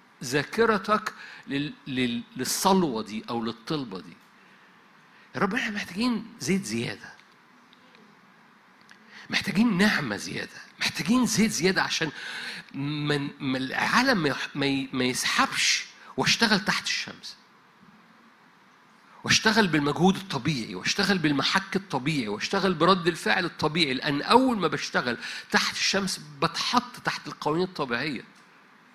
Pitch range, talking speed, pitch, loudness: 140-205 Hz, 100 wpm, 175 Hz, -25 LUFS